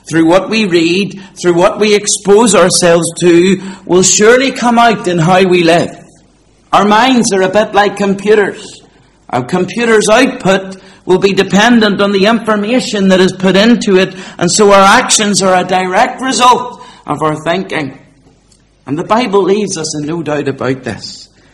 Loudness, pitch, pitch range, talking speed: -9 LUFS, 190 Hz, 175-215 Hz, 165 wpm